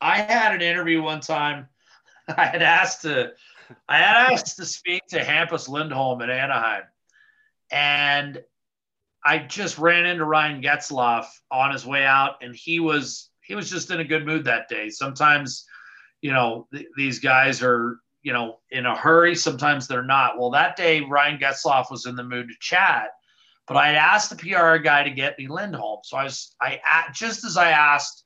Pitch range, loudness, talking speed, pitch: 130-165 Hz, -20 LUFS, 185 wpm, 145 Hz